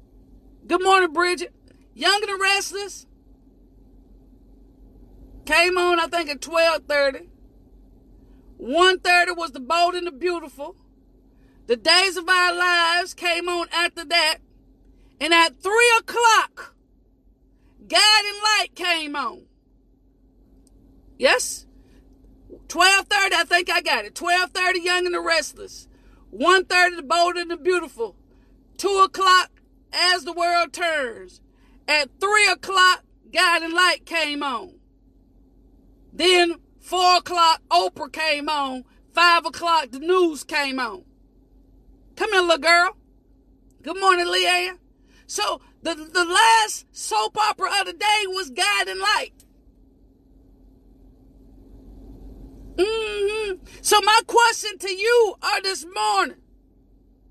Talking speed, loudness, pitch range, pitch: 115 wpm, -19 LUFS, 335-385 Hz, 360 Hz